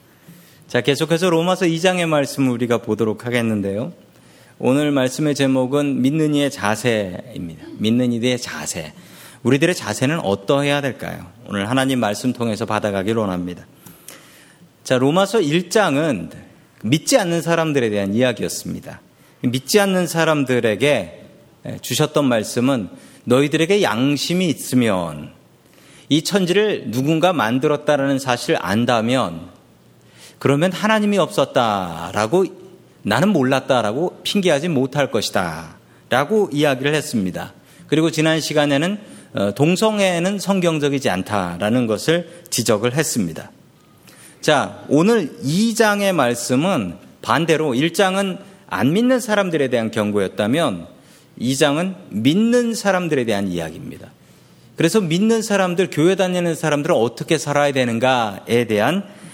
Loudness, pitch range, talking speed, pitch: -18 LUFS, 120-175 Hz, 295 characters per minute, 145 Hz